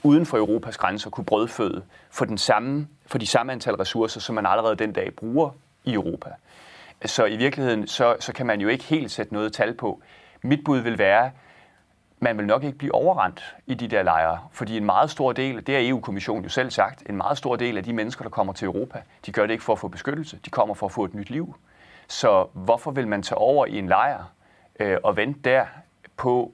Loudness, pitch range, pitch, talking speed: -24 LUFS, 110-140 Hz, 125 Hz, 235 wpm